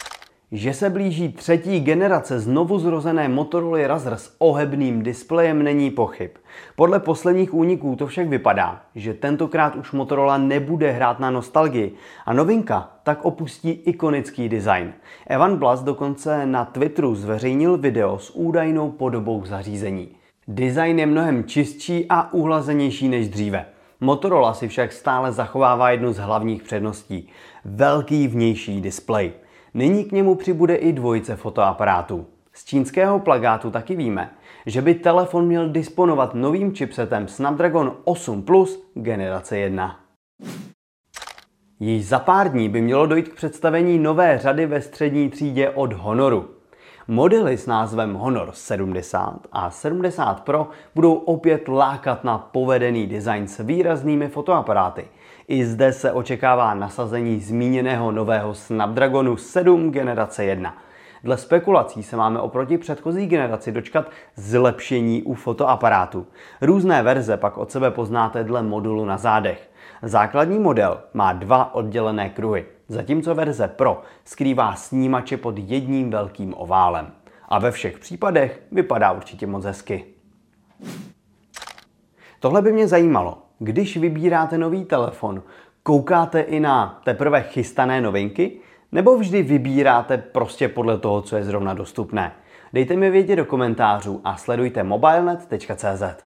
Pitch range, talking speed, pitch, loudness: 115-160 Hz, 130 wpm, 135 Hz, -20 LUFS